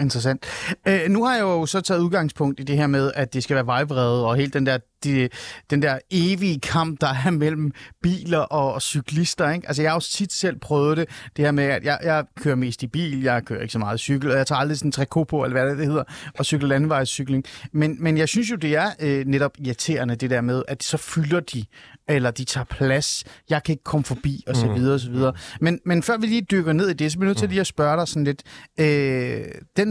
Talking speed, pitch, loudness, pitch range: 255 wpm, 145 Hz, -22 LUFS, 135-160 Hz